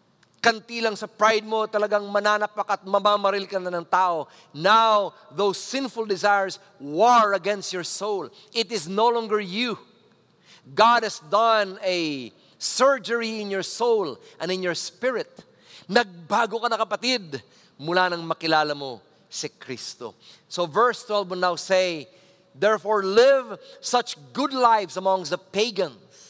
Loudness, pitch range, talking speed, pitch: -23 LUFS, 185-225 Hz, 140 wpm, 205 Hz